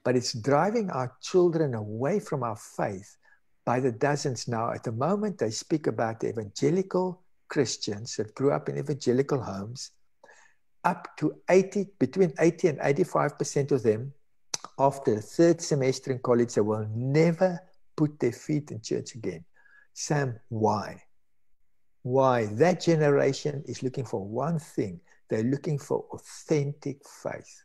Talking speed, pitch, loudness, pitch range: 145 wpm, 140 Hz, -28 LUFS, 120-165 Hz